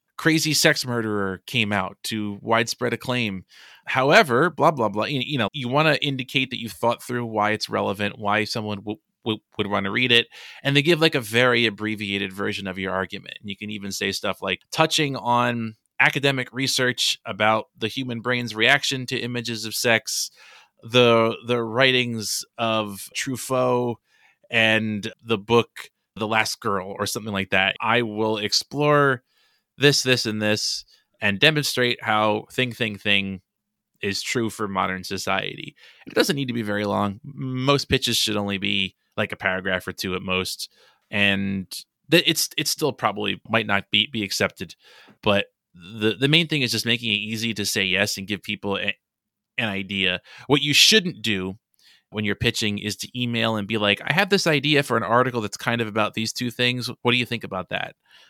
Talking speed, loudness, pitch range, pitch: 185 wpm, -22 LUFS, 105-125 Hz, 110 Hz